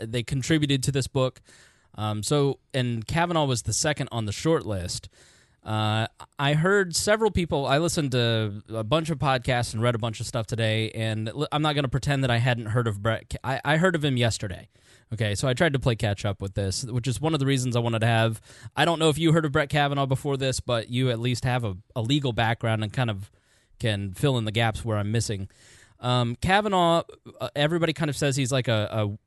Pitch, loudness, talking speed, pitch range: 125 Hz, -25 LUFS, 235 wpm, 110-140 Hz